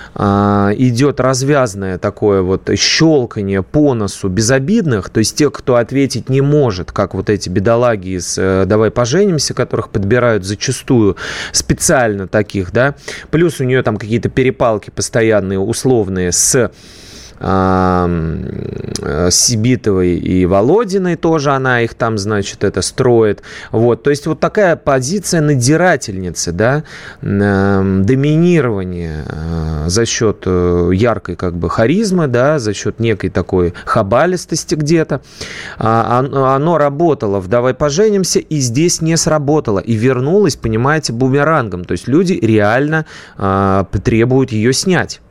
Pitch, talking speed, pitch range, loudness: 115 Hz, 120 wpm, 100-145 Hz, -13 LUFS